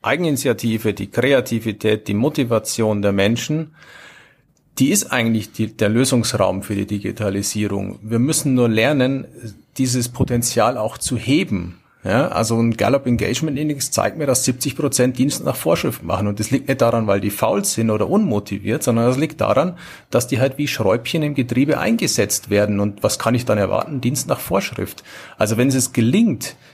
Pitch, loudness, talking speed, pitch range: 115 Hz, -19 LUFS, 170 wpm, 105-135 Hz